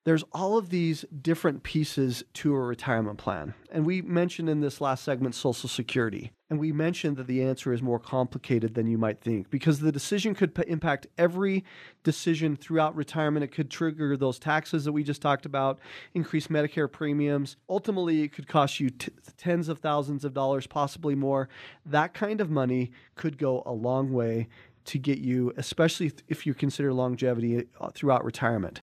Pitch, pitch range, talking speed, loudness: 145 Hz, 130-160 Hz, 180 wpm, -28 LUFS